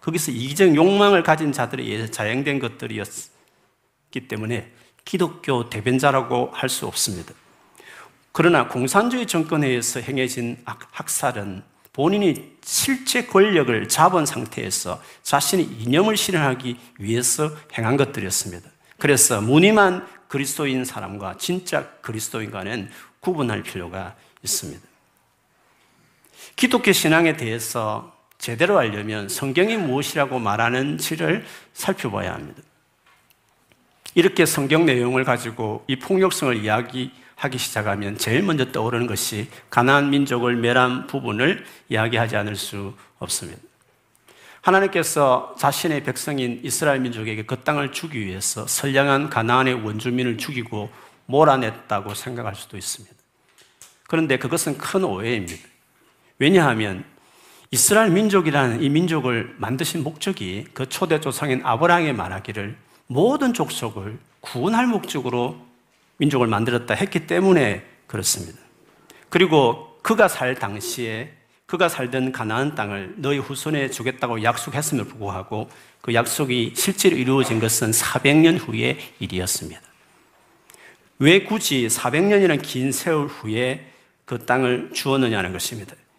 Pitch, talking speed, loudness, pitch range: 130 Hz, 305 characters per minute, -21 LUFS, 115-155 Hz